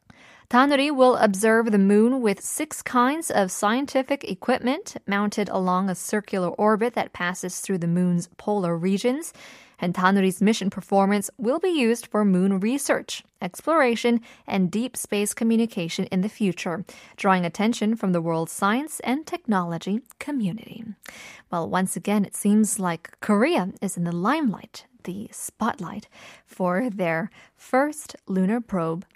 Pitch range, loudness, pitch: 190-245 Hz, -23 LUFS, 210 Hz